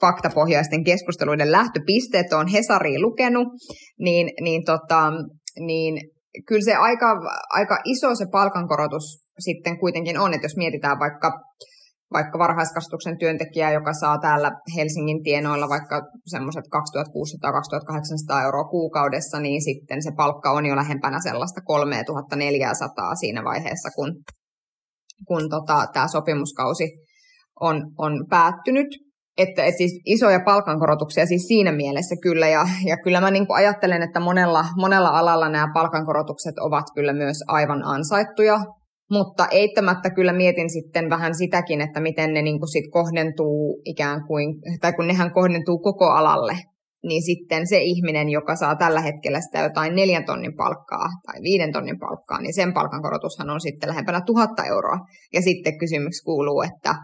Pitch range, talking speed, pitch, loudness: 150-180 Hz, 140 wpm, 165 Hz, -21 LUFS